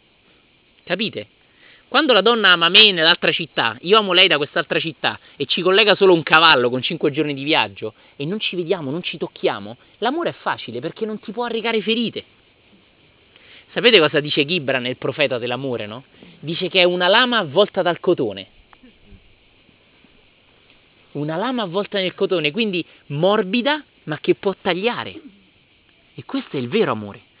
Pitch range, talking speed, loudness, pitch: 140-200 Hz, 160 wpm, -17 LUFS, 170 Hz